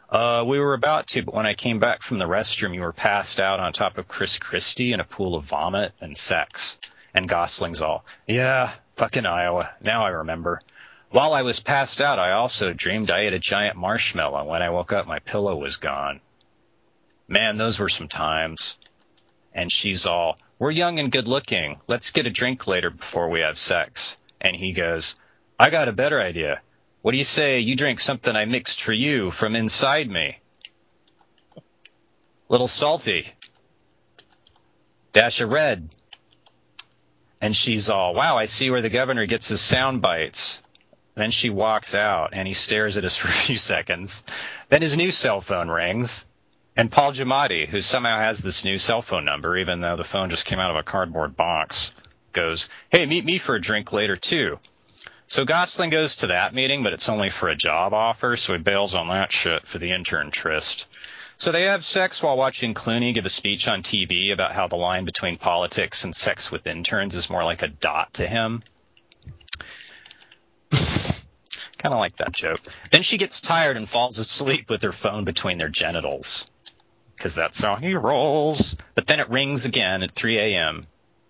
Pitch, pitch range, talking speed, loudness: 110 Hz, 90-130 Hz, 190 wpm, -22 LUFS